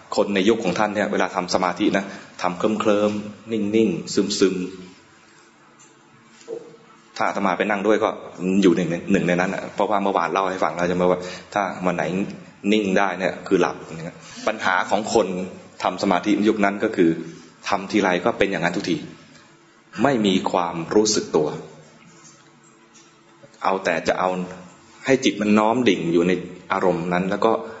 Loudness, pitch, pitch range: -21 LUFS, 95 Hz, 90-105 Hz